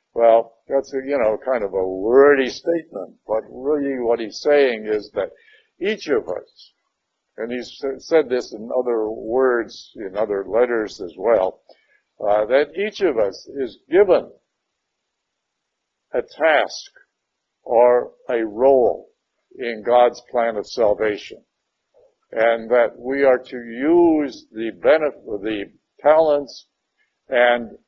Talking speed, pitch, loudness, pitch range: 130 wpm, 125 Hz, -19 LUFS, 115-155 Hz